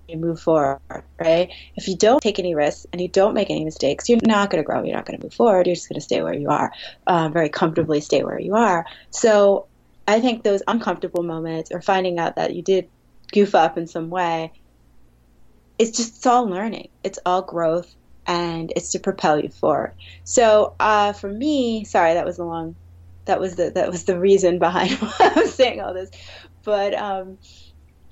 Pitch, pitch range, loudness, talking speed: 175 Hz, 160-200 Hz, -20 LUFS, 210 wpm